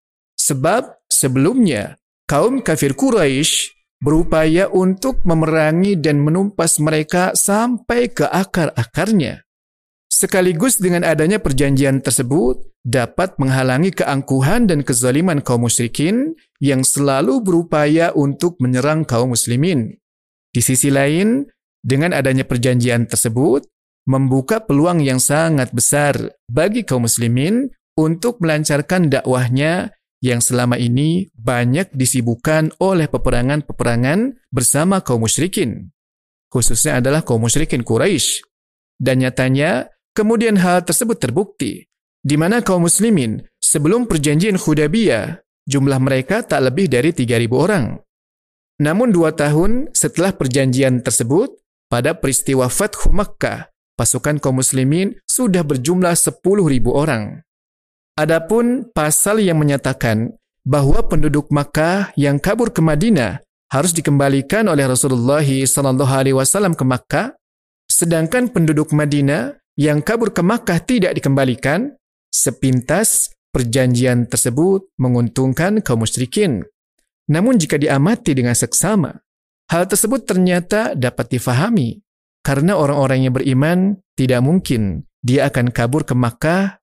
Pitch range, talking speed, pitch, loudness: 130-185 Hz, 110 wpm, 150 Hz, -16 LUFS